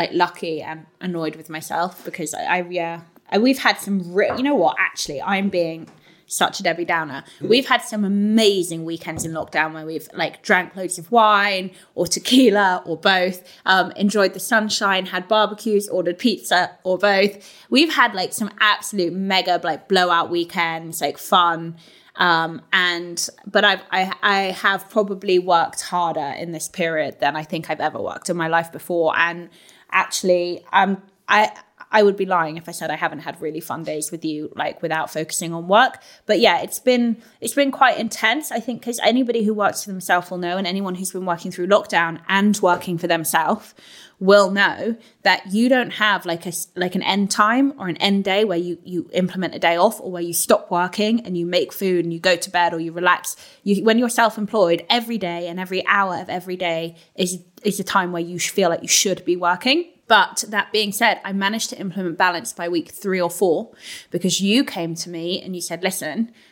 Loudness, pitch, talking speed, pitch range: -20 LUFS, 185 Hz, 205 wpm, 170-205 Hz